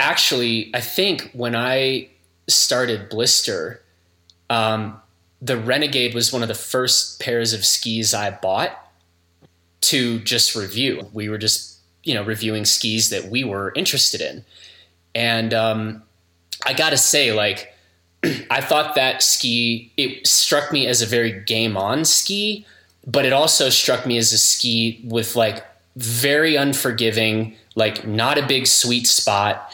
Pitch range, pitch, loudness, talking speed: 105-125 Hz, 115 Hz, -18 LUFS, 145 wpm